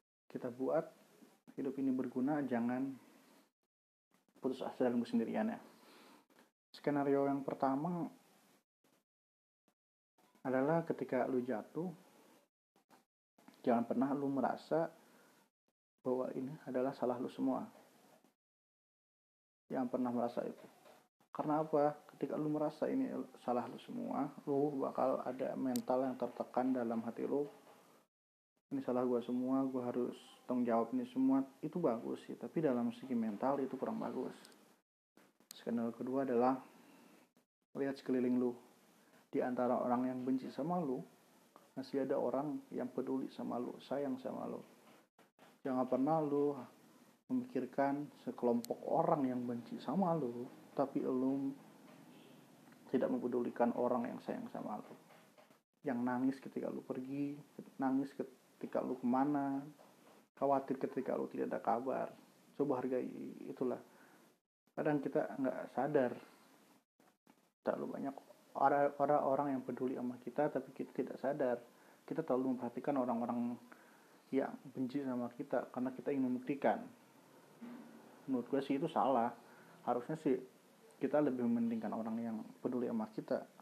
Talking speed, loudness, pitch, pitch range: 125 wpm, -39 LUFS, 135 Hz, 125-145 Hz